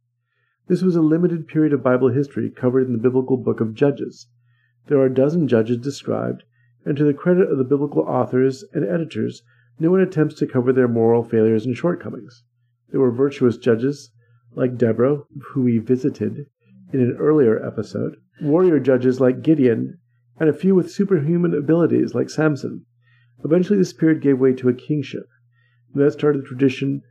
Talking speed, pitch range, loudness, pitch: 175 wpm, 120-150 Hz, -19 LUFS, 130 Hz